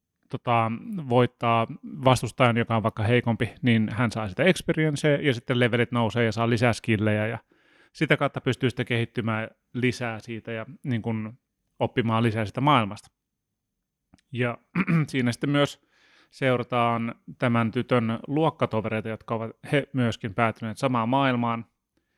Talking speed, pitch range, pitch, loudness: 135 wpm, 115-130 Hz, 120 Hz, -25 LUFS